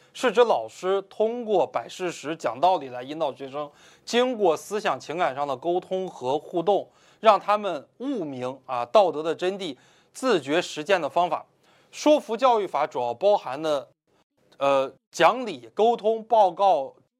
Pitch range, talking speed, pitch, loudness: 145-220 Hz, 225 characters per minute, 185 Hz, -24 LUFS